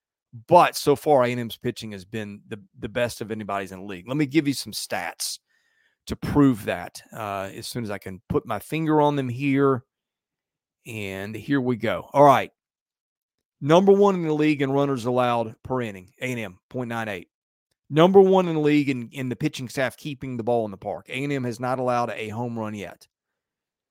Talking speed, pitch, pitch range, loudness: 200 wpm, 125 Hz, 110-140 Hz, -23 LUFS